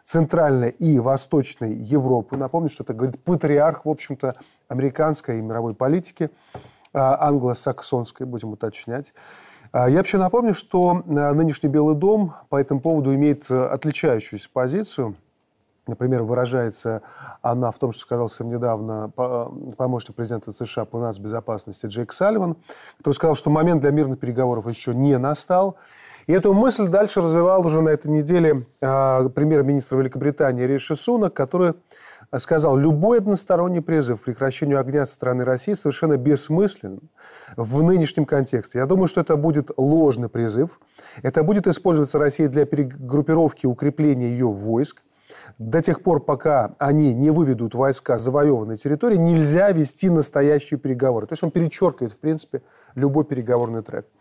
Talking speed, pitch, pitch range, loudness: 140 wpm, 145 Hz, 125-160 Hz, -20 LUFS